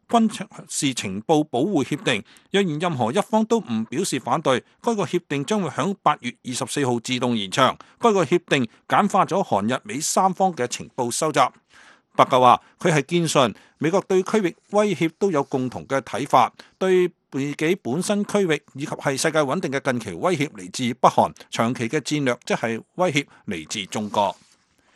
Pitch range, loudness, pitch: 130-190 Hz, -22 LUFS, 155 Hz